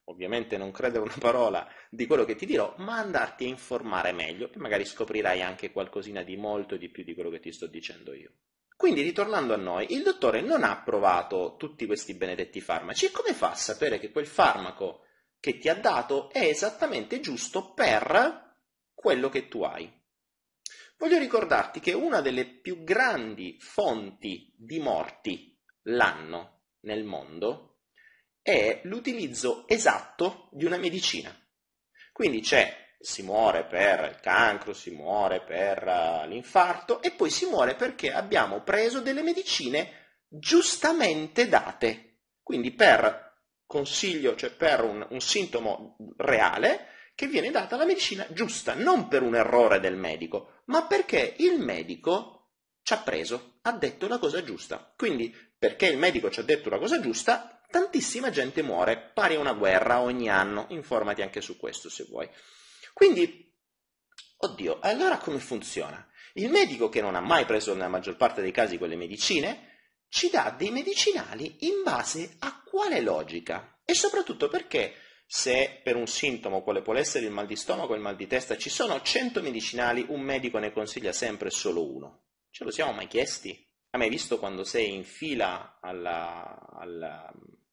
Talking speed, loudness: 160 wpm, -27 LUFS